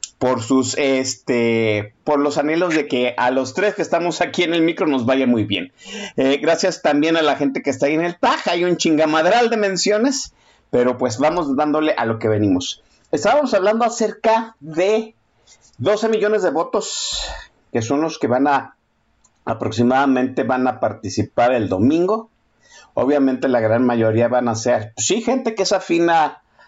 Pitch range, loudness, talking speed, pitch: 125-180 Hz, -18 LUFS, 180 wpm, 145 Hz